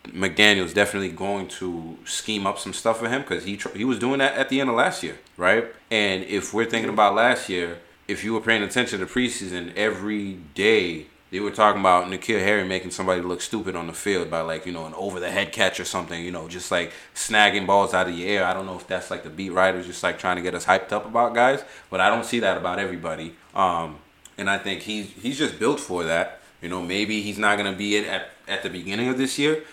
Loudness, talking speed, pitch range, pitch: -23 LUFS, 255 wpm, 90-105 Hz, 100 Hz